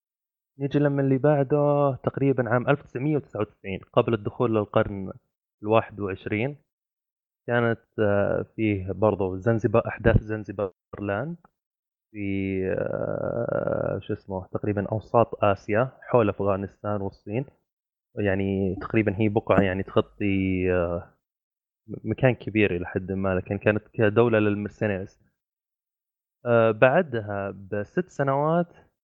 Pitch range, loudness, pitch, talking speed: 100-125 Hz, -25 LUFS, 105 Hz, 95 wpm